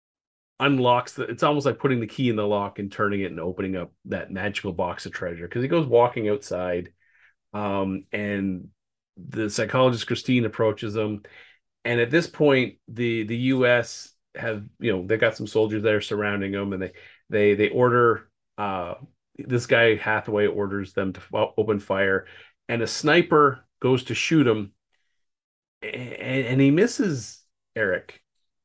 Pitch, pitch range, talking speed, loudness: 110 Hz, 100-120 Hz, 160 wpm, -24 LUFS